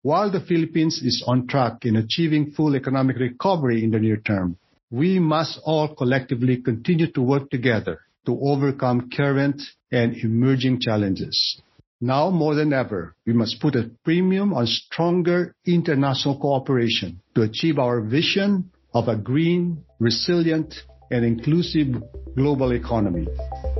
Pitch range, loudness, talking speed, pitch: 115-155 Hz, -22 LUFS, 135 wpm, 130 Hz